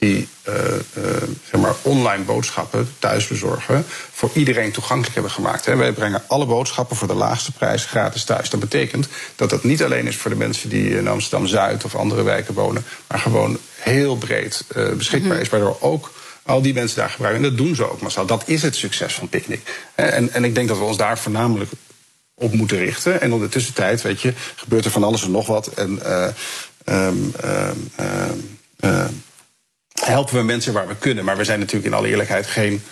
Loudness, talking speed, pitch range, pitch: -20 LUFS, 190 wpm, 105-125 Hz, 115 Hz